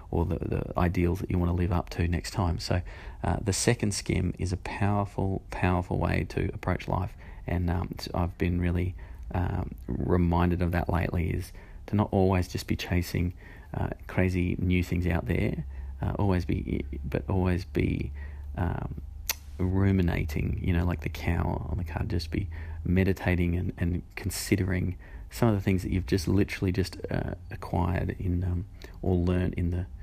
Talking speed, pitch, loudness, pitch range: 175 wpm, 90 Hz, -29 LUFS, 85-95 Hz